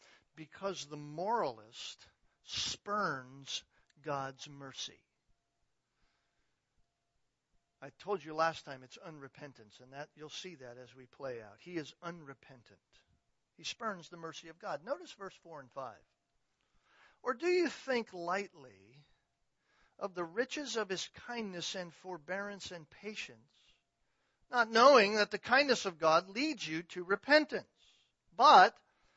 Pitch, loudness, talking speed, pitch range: 175 Hz, -33 LUFS, 130 wpm, 145-210 Hz